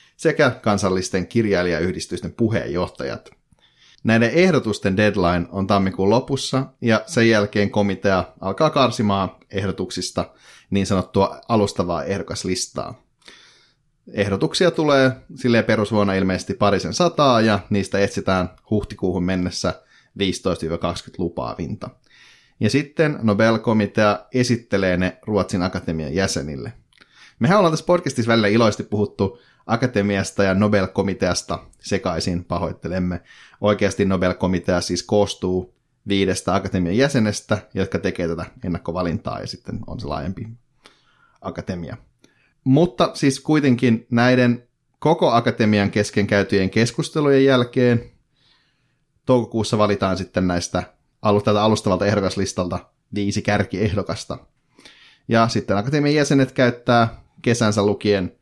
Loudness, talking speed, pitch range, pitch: -20 LUFS, 100 wpm, 95-120 Hz, 105 Hz